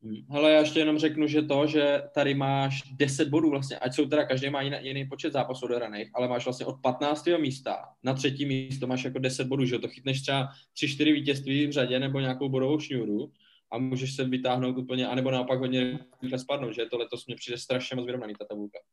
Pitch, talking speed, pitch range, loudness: 130 Hz, 220 wpm, 125-145 Hz, -28 LUFS